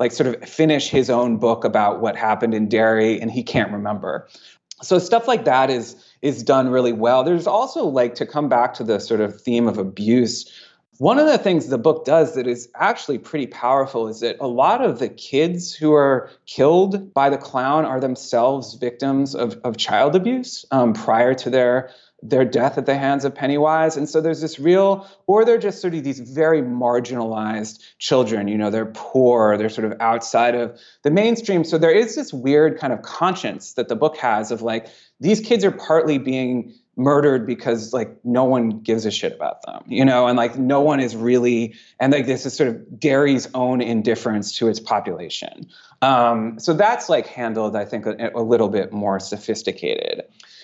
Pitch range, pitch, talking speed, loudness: 115-150 Hz, 130 Hz, 200 wpm, -19 LUFS